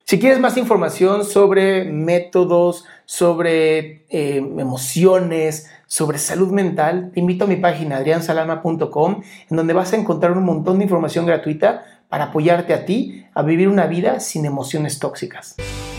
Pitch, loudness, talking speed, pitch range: 170 Hz, -17 LUFS, 145 wpm, 155-185 Hz